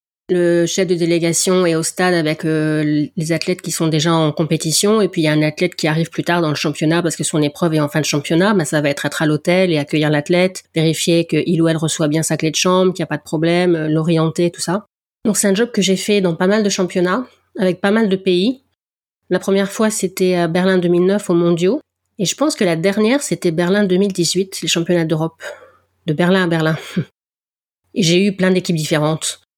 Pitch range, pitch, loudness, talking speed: 160-185 Hz, 175 Hz, -16 LUFS, 235 wpm